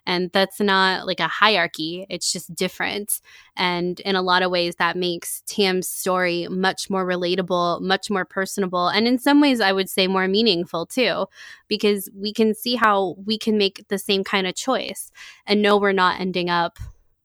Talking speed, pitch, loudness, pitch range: 190 wpm, 190 Hz, -21 LUFS, 180-205 Hz